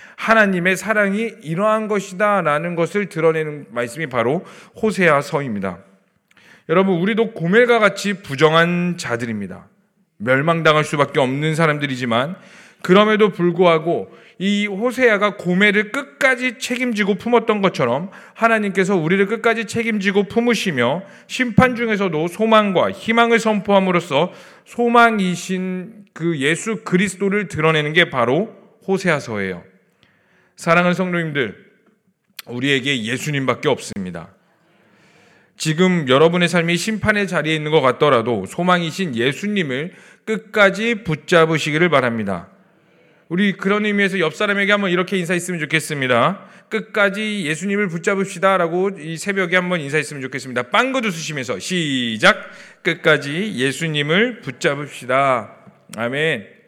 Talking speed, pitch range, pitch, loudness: 320 characters per minute, 155-210 Hz, 185 Hz, -18 LUFS